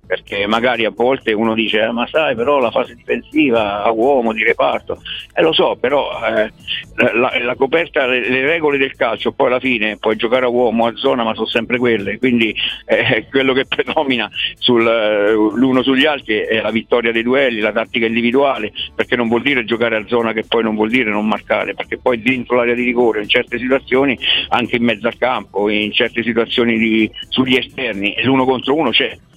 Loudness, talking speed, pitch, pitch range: -15 LUFS, 200 wpm, 120 Hz, 110-130 Hz